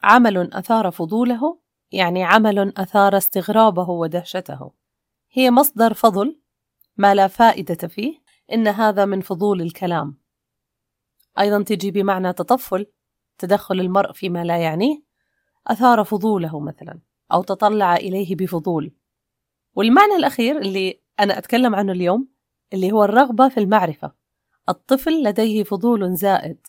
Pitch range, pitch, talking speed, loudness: 185-230 Hz, 200 Hz, 115 wpm, -18 LUFS